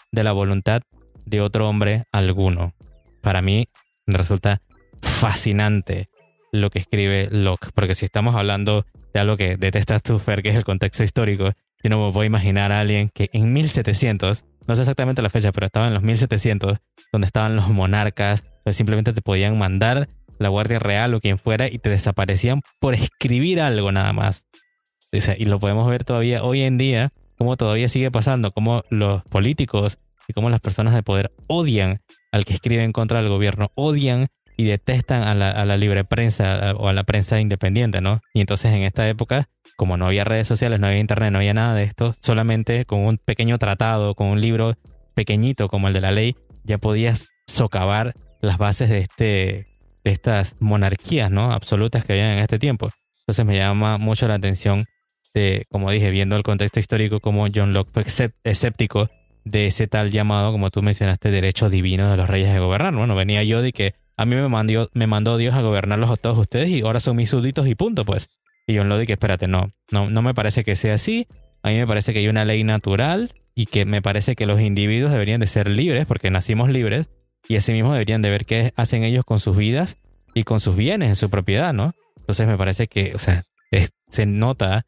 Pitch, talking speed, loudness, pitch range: 105 Hz, 205 wpm, -20 LUFS, 100-115 Hz